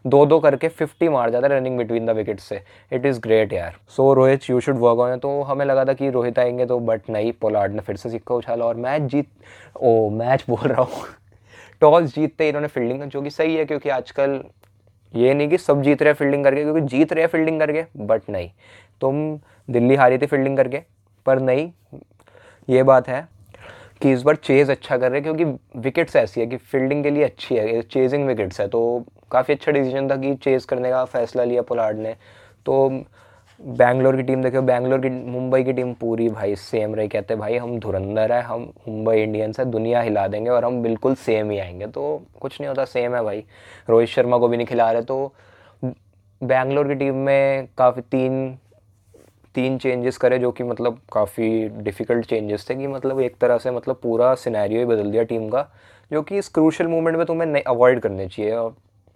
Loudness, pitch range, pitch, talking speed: -20 LUFS, 115-140 Hz, 125 Hz, 210 wpm